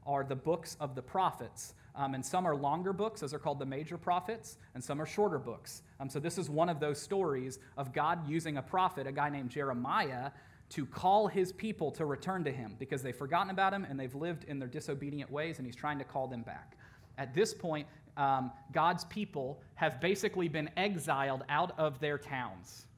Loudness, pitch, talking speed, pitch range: -36 LUFS, 145 Hz, 210 wpm, 135-170 Hz